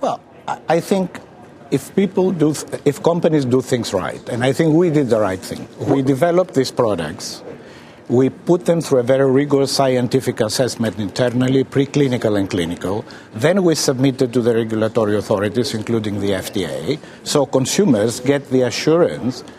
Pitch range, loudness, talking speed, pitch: 120-150 Hz, -18 LUFS, 155 wpm, 130 Hz